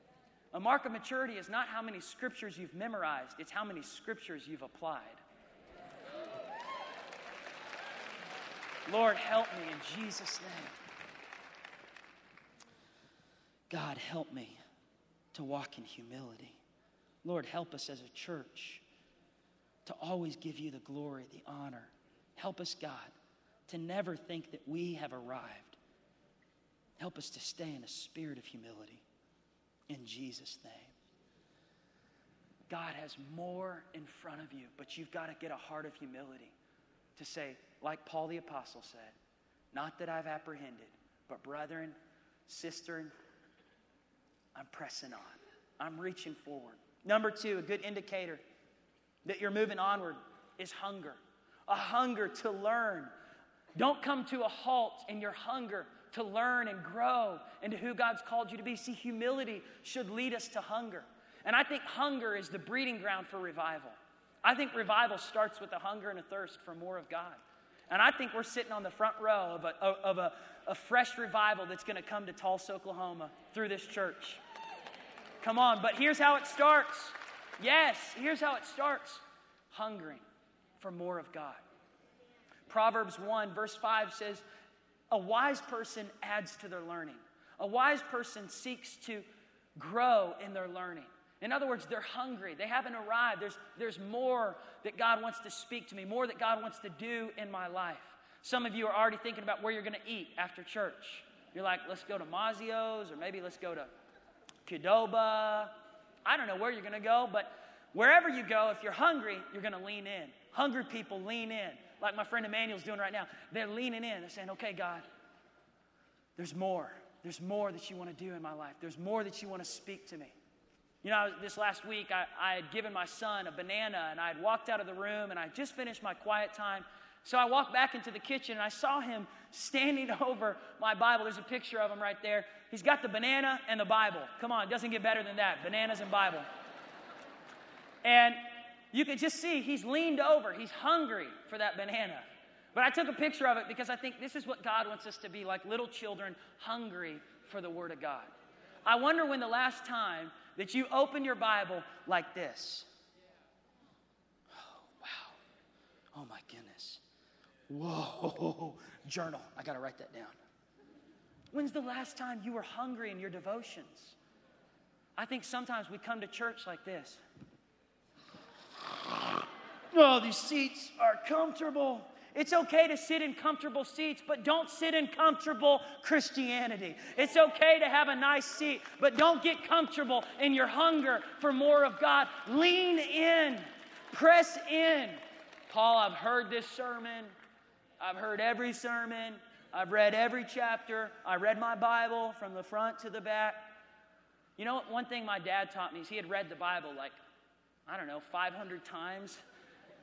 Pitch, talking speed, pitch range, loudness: 220 Hz, 175 wpm, 185-250 Hz, -34 LUFS